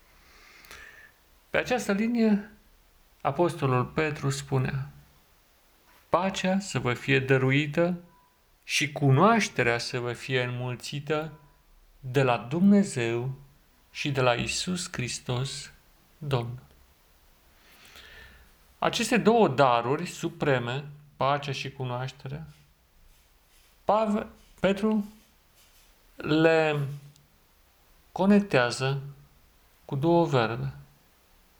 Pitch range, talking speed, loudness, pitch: 120-165 Hz, 75 wpm, -27 LUFS, 135 Hz